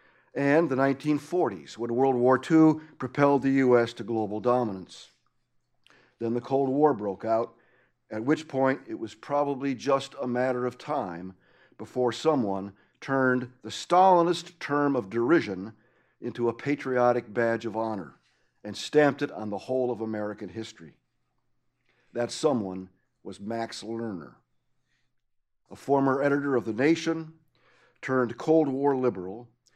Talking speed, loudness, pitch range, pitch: 135 wpm, -27 LUFS, 115-145 Hz, 125 Hz